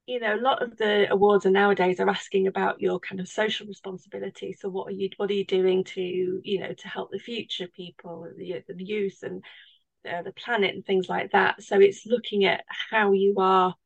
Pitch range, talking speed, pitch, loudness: 185-205 Hz, 225 wpm, 195 Hz, -25 LUFS